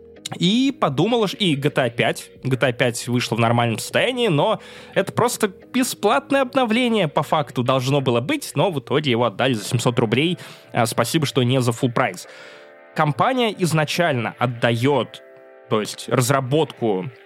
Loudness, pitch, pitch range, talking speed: -20 LUFS, 135 Hz, 120-175 Hz, 145 wpm